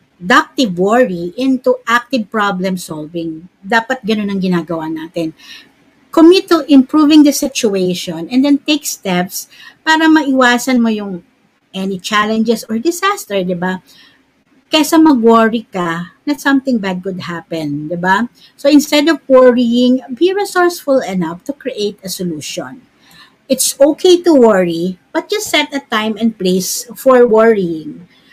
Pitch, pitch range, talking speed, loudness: 235 Hz, 185-280 Hz, 135 wpm, -13 LUFS